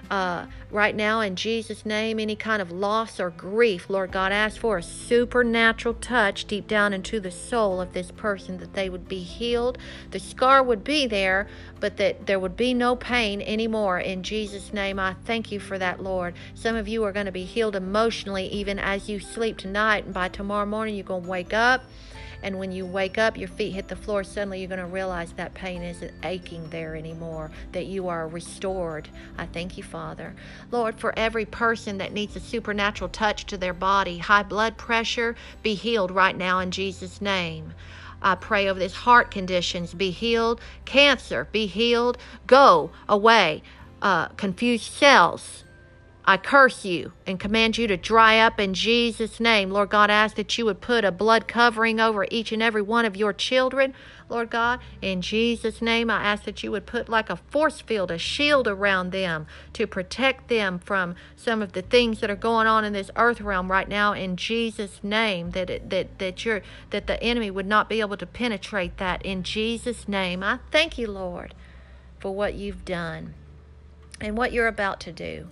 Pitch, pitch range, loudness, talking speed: 205 Hz, 190-225 Hz, -23 LUFS, 195 wpm